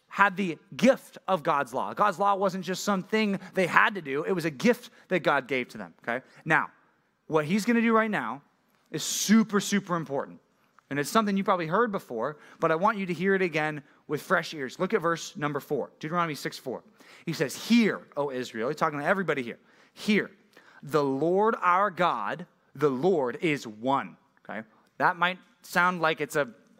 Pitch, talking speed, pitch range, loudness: 185 Hz, 195 wpm, 155-210 Hz, -27 LUFS